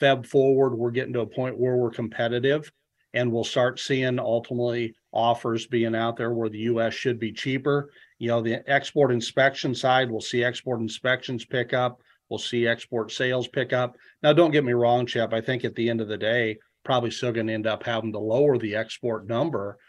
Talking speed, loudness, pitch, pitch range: 205 wpm, -25 LUFS, 120 Hz, 115-130 Hz